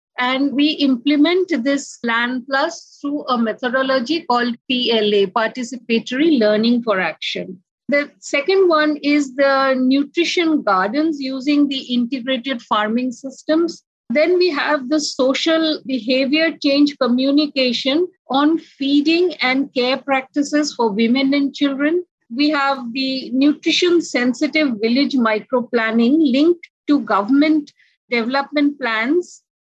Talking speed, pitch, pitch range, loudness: 115 wpm, 275 Hz, 250-300 Hz, -17 LUFS